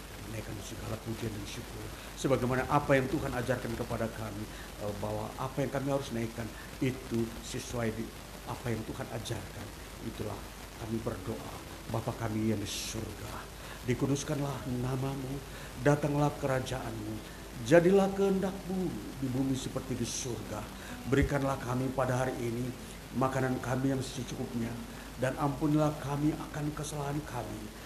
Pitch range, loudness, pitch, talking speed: 110-135 Hz, -34 LUFS, 125 Hz, 125 wpm